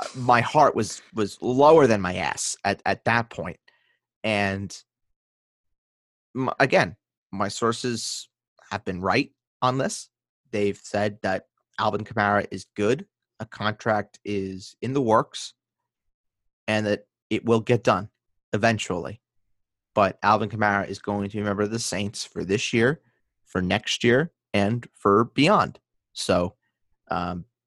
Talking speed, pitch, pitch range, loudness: 140 wpm, 105 Hz, 95-115 Hz, -24 LUFS